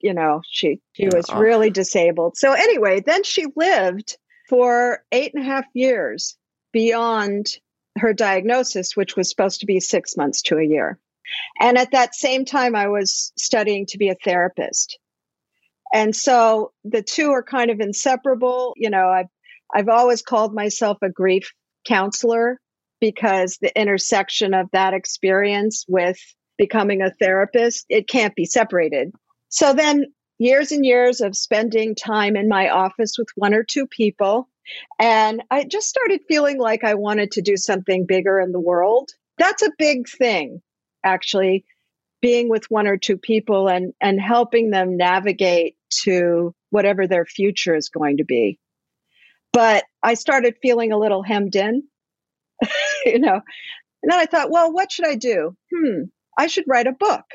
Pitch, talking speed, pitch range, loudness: 220 Hz, 160 wpm, 195-255 Hz, -19 LUFS